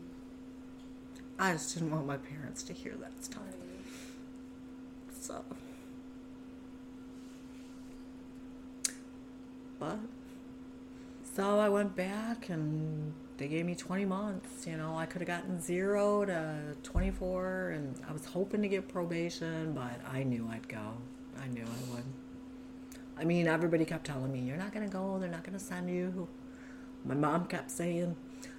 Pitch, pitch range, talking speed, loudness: 200 Hz, 160-255 Hz, 145 wpm, -37 LUFS